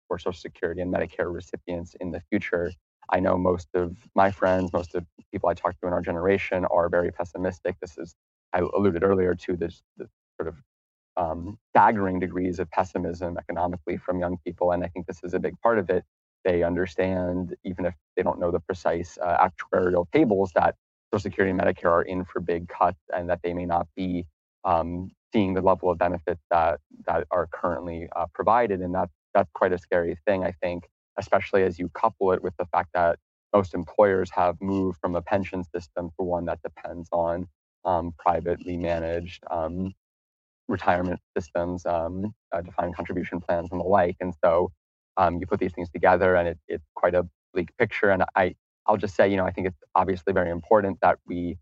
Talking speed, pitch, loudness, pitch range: 200 wpm, 90 Hz, -26 LUFS, 85-95 Hz